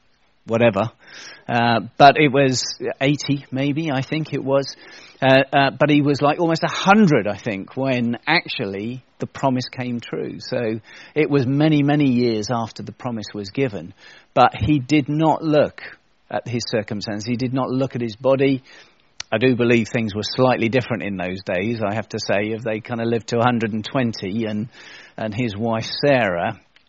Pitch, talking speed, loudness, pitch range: 125 Hz, 175 wpm, -20 LUFS, 110-140 Hz